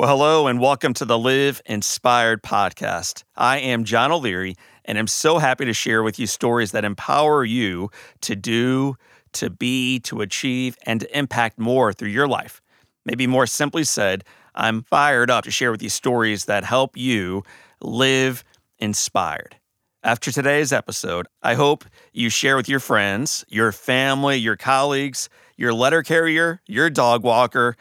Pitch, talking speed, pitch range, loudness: 125 Hz, 160 wpm, 115-140 Hz, -20 LUFS